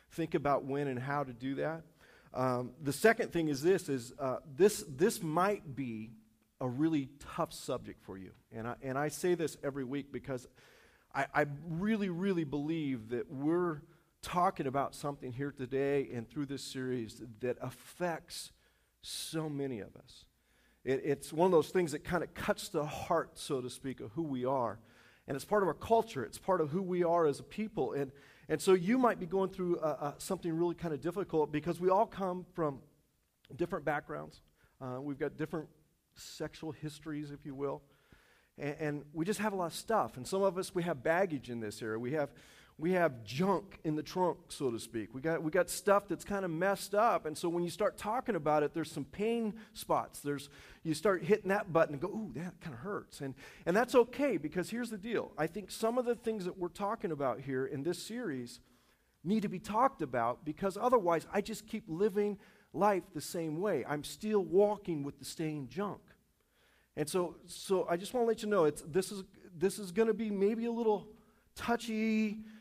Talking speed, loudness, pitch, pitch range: 210 wpm, -35 LUFS, 165 Hz, 140-195 Hz